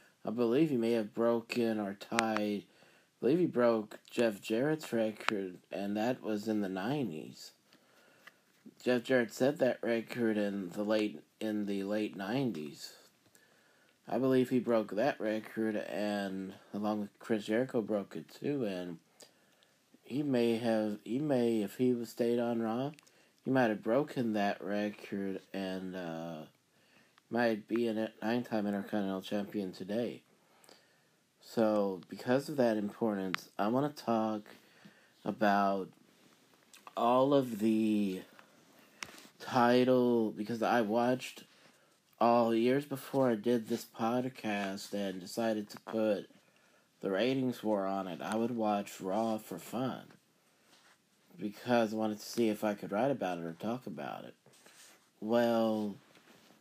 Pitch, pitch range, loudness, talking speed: 110 Hz, 100-120 Hz, -34 LUFS, 140 wpm